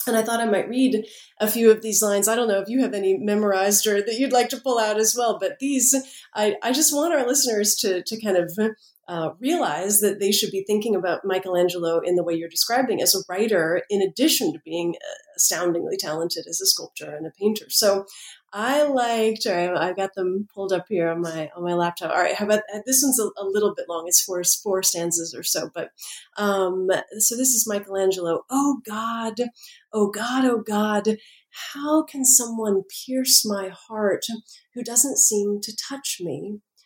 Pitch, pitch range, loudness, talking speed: 210 Hz, 190-240 Hz, -21 LUFS, 205 wpm